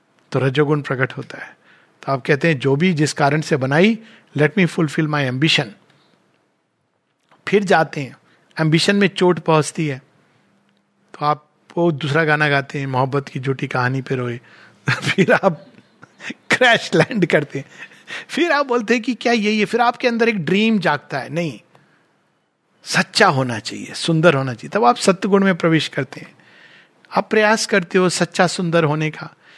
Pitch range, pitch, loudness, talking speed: 140-190 Hz, 160 Hz, -18 LUFS, 175 wpm